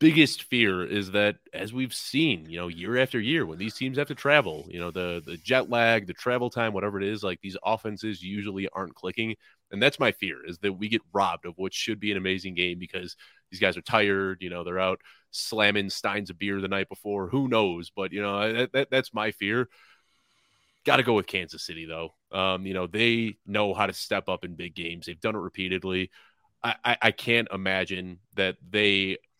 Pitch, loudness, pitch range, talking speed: 100 Hz, -27 LUFS, 95-115 Hz, 220 wpm